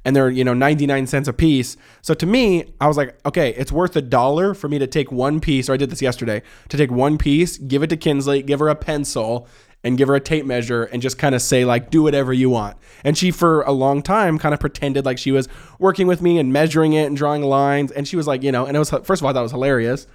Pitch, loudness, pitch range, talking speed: 140 Hz, -18 LUFS, 130-155 Hz, 285 wpm